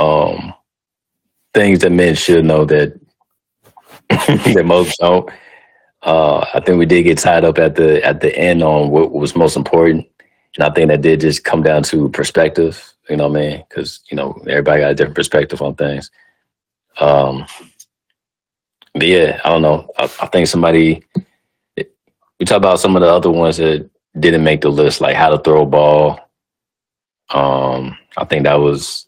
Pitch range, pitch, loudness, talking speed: 75-80 Hz, 75 Hz, -12 LUFS, 180 wpm